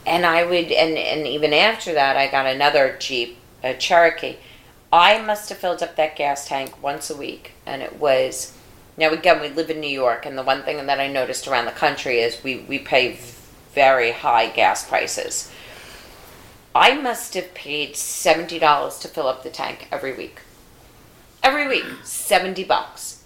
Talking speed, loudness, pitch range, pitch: 180 wpm, -20 LUFS, 130-170 Hz, 145 Hz